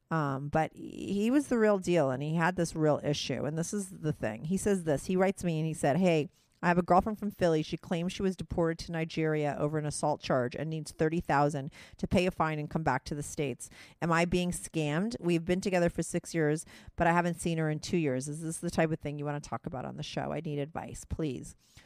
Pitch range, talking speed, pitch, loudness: 150-175 Hz, 260 wpm, 160 Hz, -31 LUFS